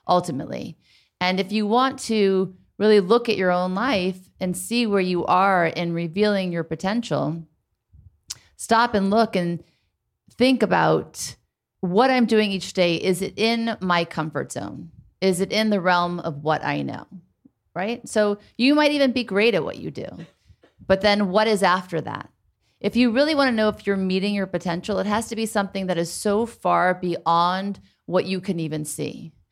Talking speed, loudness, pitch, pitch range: 185 wpm, -22 LUFS, 190 Hz, 170-215 Hz